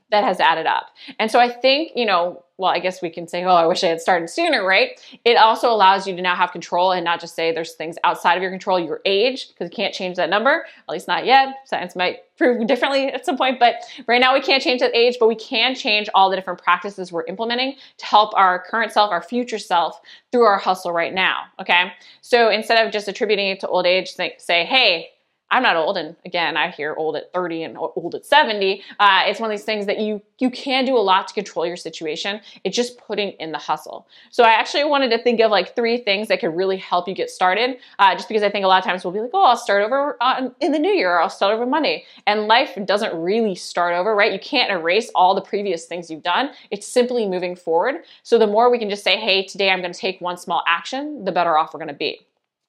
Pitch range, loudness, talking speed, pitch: 180-245 Hz, -19 LUFS, 260 wpm, 205 Hz